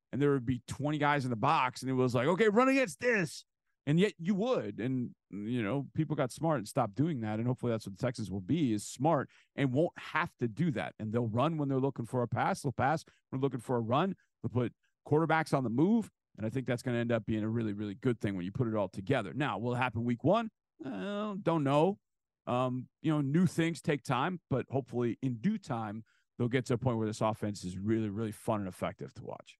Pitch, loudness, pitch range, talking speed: 130 Hz, -33 LUFS, 115-155 Hz, 255 wpm